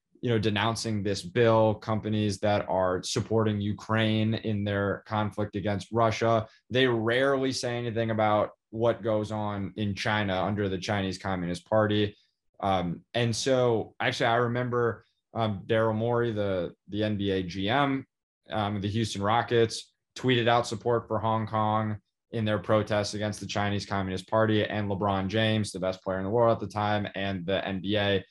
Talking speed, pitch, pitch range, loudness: 160 wpm, 105 Hz, 100-115 Hz, -28 LUFS